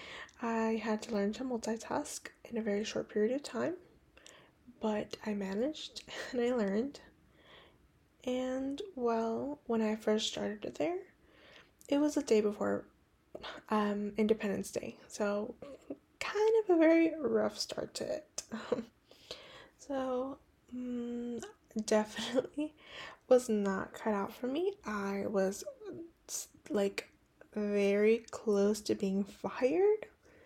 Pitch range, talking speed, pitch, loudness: 210-275 Hz, 120 wpm, 230 Hz, -35 LUFS